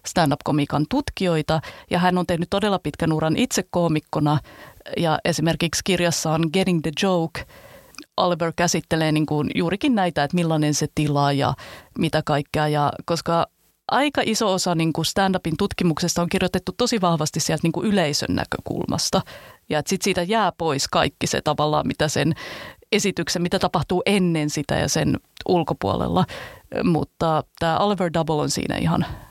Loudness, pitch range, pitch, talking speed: -22 LUFS, 155-185 Hz, 170 Hz, 145 wpm